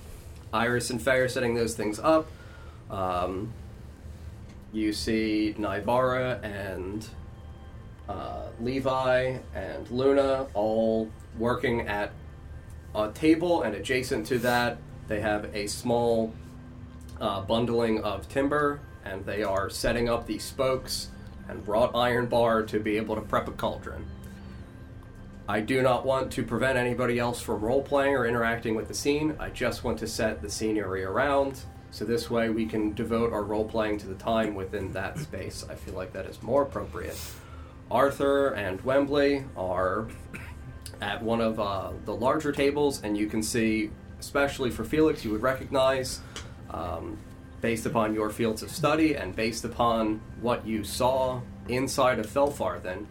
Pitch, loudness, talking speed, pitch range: 110 Hz, -28 LUFS, 150 wpm, 105-125 Hz